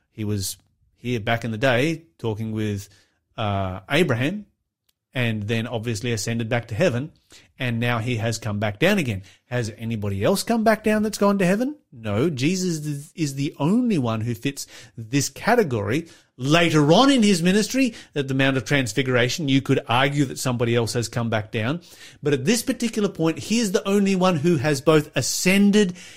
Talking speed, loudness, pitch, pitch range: 185 wpm, -22 LUFS, 135 Hz, 115-175 Hz